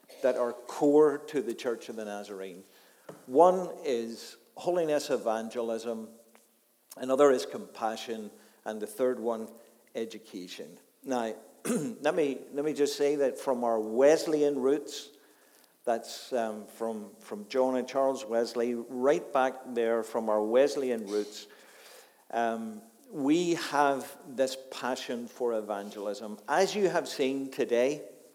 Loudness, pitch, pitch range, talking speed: -30 LUFS, 120 Hz, 110-135 Hz, 125 wpm